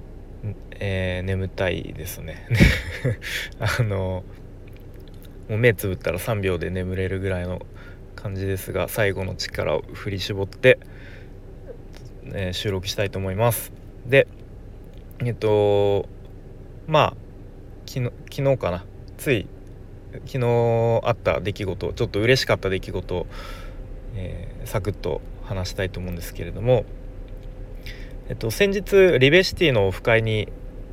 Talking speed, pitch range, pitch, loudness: 240 characters per minute, 95-115 Hz, 100 Hz, -23 LUFS